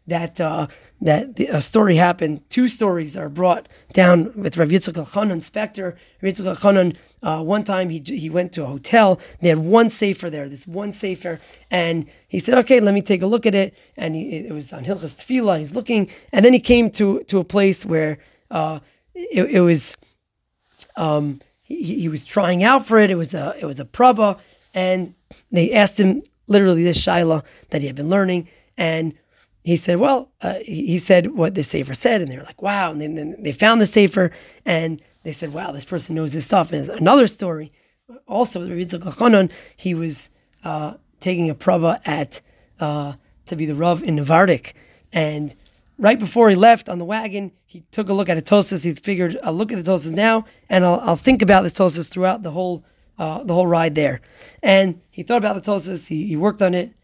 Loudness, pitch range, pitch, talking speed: -18 LUFS, 160-200 Hz, 180 Hz, 205 wpm